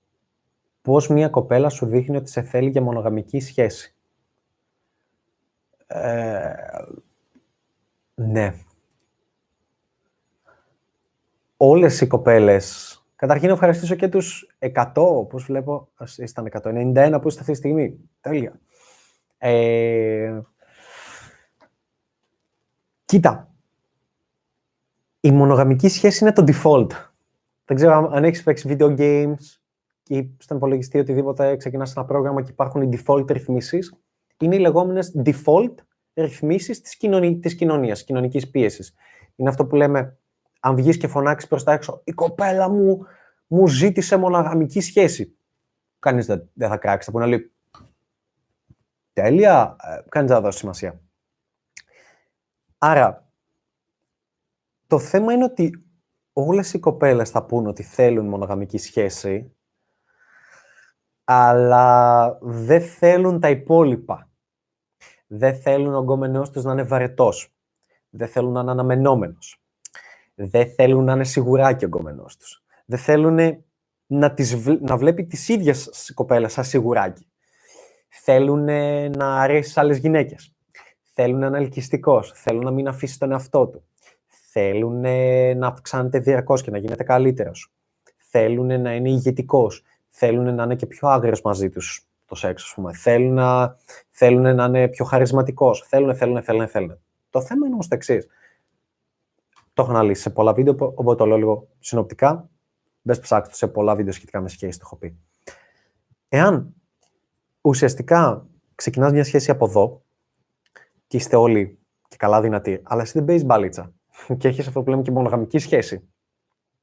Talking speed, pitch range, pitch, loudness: 135 wpm, 120-150 Hz, 135 Hz, -19 LUFS